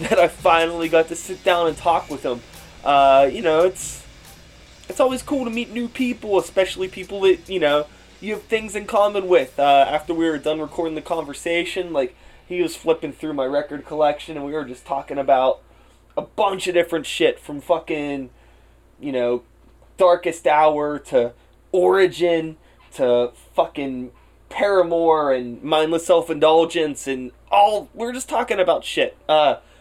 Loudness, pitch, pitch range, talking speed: -20 LUFS, 160 Hz, 140-185 Hz, 165 wpm